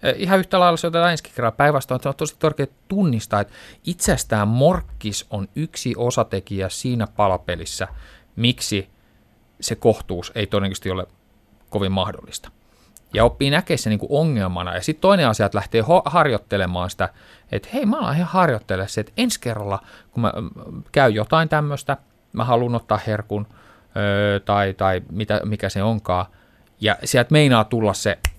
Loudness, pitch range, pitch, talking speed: -21 LUFS, 100-140 Hz, 110 Hz, 150 wpm